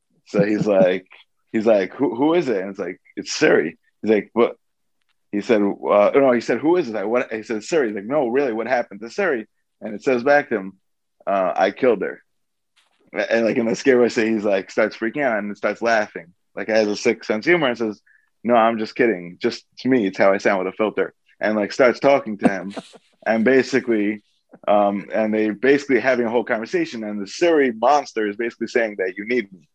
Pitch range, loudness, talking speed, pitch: 105-125 Hz, -20 LUFS, 230 wpm, 110 Hz